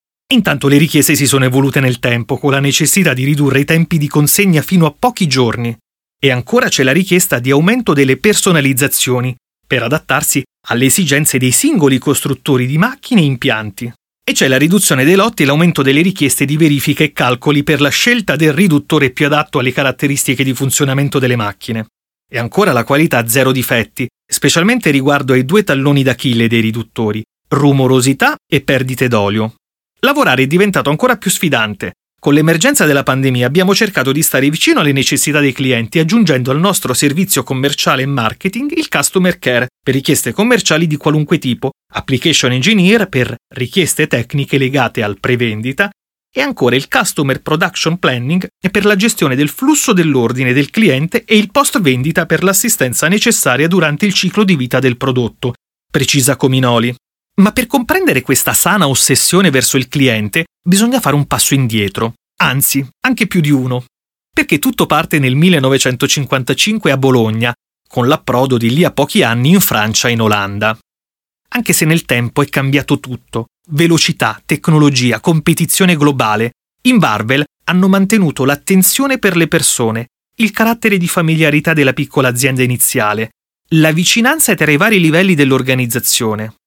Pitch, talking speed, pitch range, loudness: 145 Hz, 160 wpm, 130-175 Hz, -12 LUFS